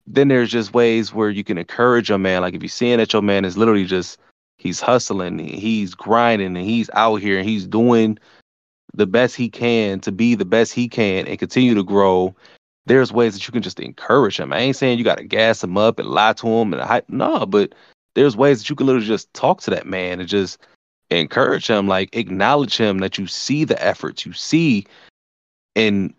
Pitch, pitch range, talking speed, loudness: 110 Hz, 95-120 Hz, 220 wpm, -18 LUFS